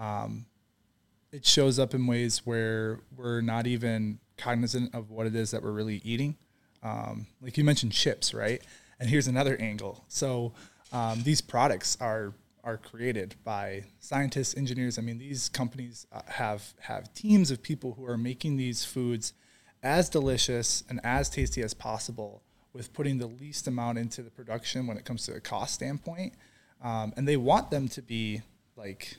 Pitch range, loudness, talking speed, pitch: 110-130 Hz, -30 LUFS, 170 wpm, 120 Hz